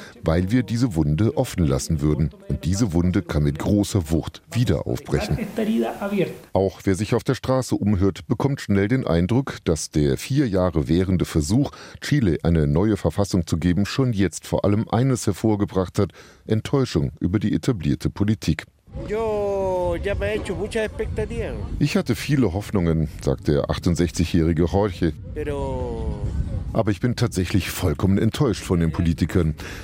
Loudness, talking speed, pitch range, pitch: -22 LUFS, 135 wpm, 85-125 Hz, 100 Hz